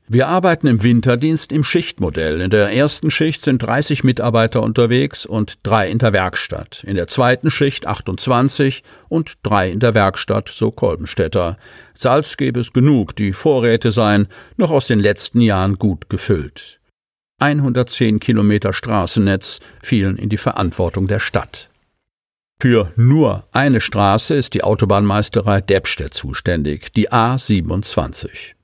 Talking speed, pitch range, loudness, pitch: 135 wpm, 100-130 Hz, -16 LUFS, 115 Hz